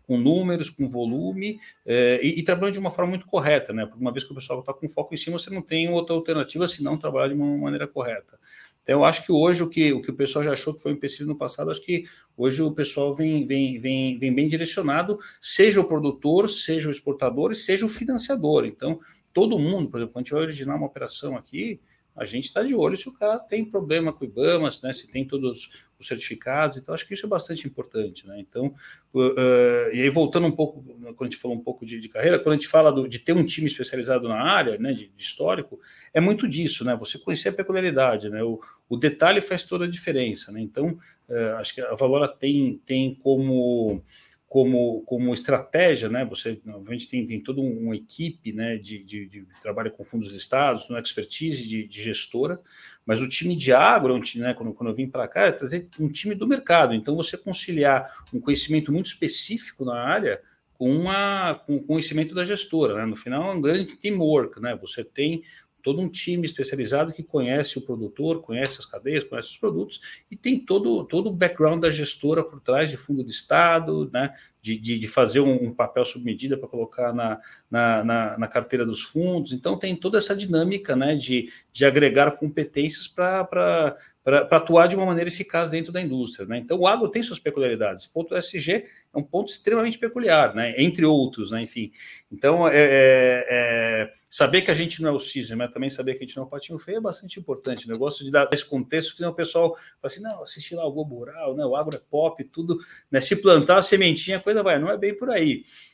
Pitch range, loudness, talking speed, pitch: 125-170 Hz, -23 LUFS, 225 wpm, 145 Hz